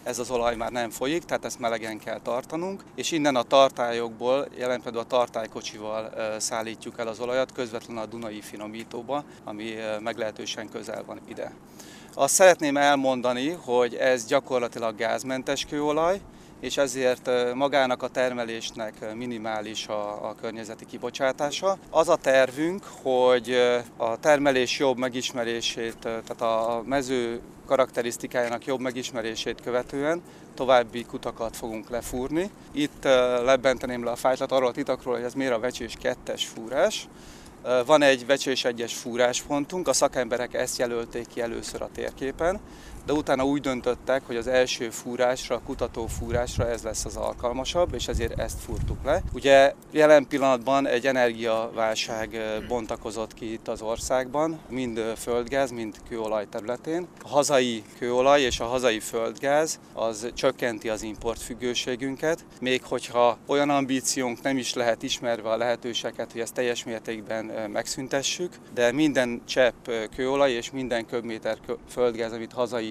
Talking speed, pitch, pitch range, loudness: 140 wpm, 125 Hz, 115-135 Hz, -26 LUFS